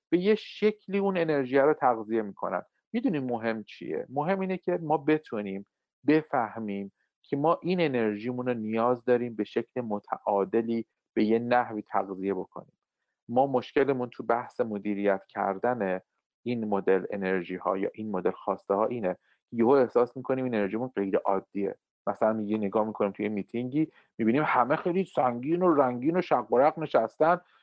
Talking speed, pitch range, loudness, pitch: 155 wpm, 105-145 Hz, -28 LUFS, 120 Hz